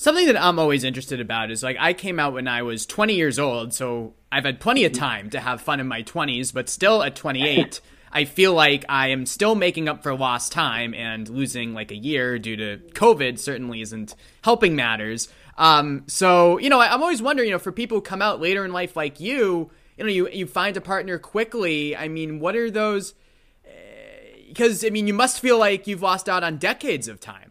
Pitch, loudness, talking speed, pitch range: 155 Hz, -21 LUFS, 225 wpm, 125-200 Hz